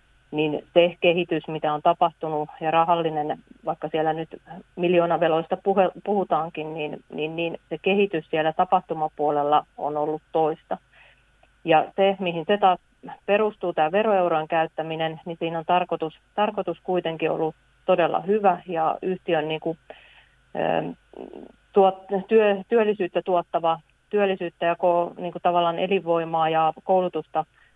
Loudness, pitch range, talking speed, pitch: -24 LUFS, 160-185 Hz, 125 wpm, 170 Hz